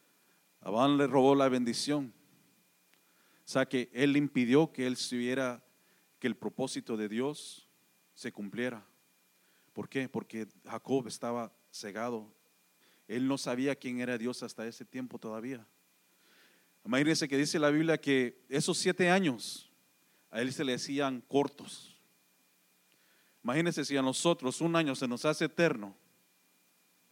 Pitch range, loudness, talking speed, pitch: 115-140 Hz, -32 LUFS, 135 wpm, 130 Hz